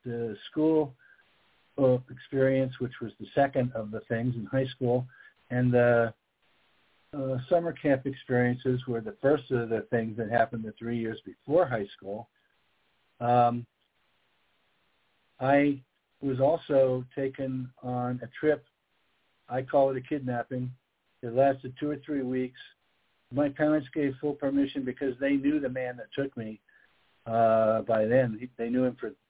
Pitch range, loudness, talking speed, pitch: 120-140 Hz, -29 LUFS, 145 wpm, 130 Hz